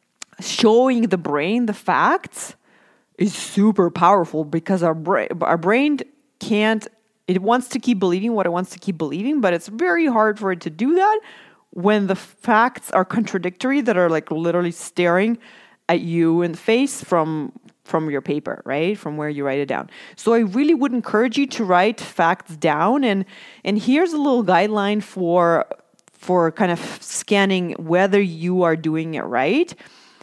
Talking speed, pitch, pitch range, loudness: 175 wpm, 195 Hz, 170-230 Hz, -19 LUFS